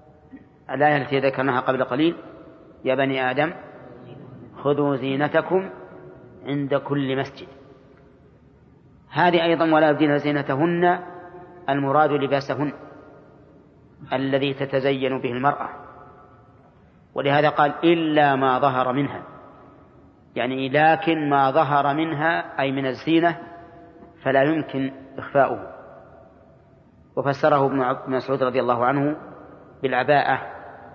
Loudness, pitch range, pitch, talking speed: -22 LUFS, 135-155 Hz, 140 Hz, 95 wpm